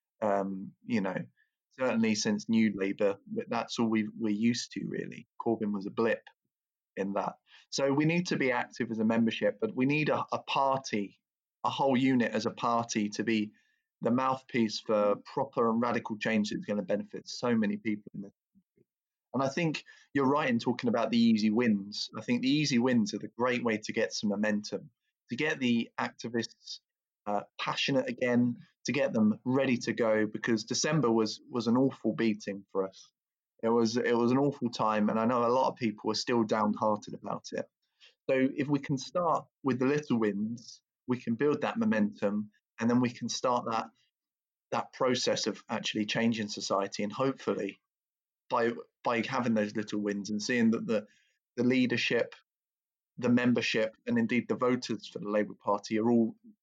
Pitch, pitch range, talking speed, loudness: 115 Hz, 110-130 Hz, 190 wpm, -31 LUFS